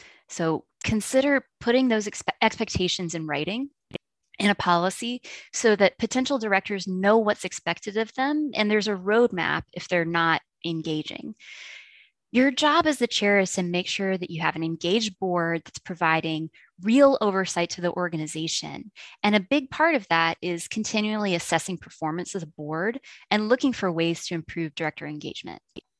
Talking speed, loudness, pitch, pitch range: 165 wpm, -25 LUFS, 195 Hz, 170-225 Hz